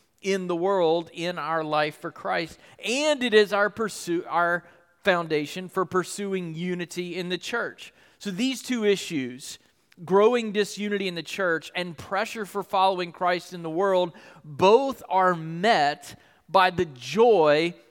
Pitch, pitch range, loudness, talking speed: 180 Hz, 170-200 Hz, -25 LUFS, 145 wpm